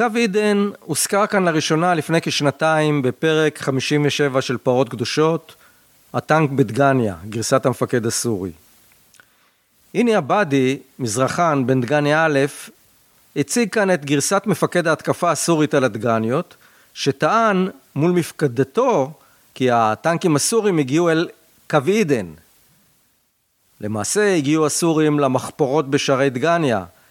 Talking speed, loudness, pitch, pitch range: 105 wpm, -18 LUFS, 150 Hz, 130-170 Hz